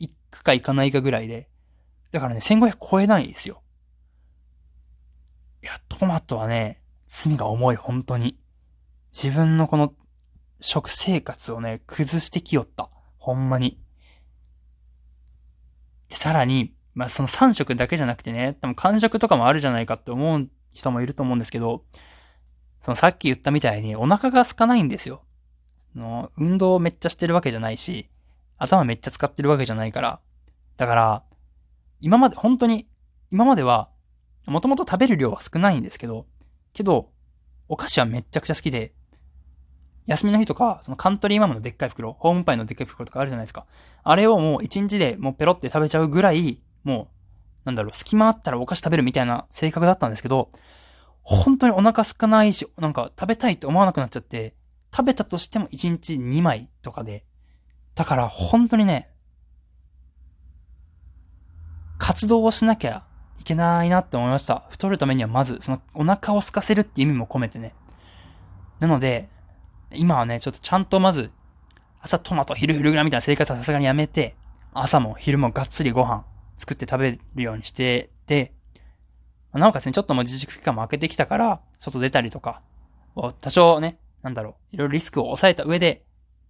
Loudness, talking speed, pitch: -21 LUFS, 355 characters per minute, 125 Hz